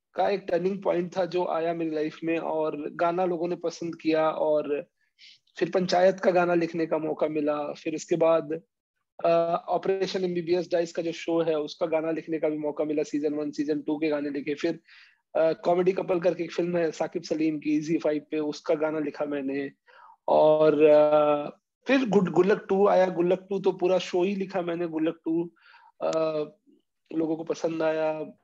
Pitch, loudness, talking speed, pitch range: 165 Hz, -26 LUFS, 185 wpm, 155-180 Hz